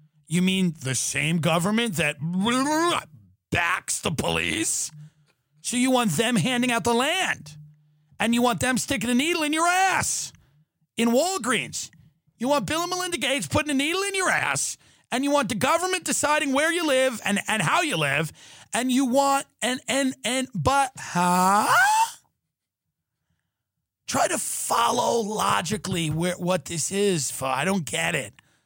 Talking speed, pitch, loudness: 160 wpm, 225 Hz, -23 LUFS